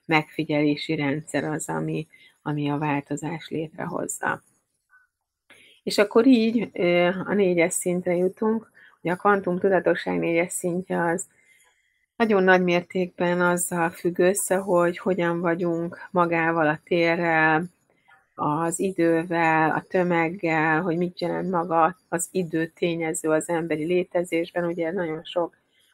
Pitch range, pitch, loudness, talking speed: 160-185 Hz, 170 Hz, -24 LUFS, 120 wpm